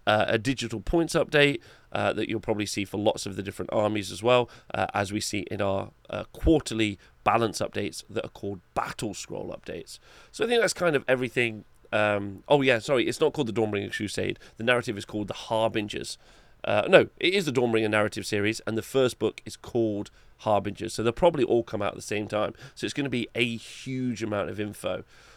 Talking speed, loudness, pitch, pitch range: 220 wpm, -27 LUFS, 110 Hz, 105-120 Hz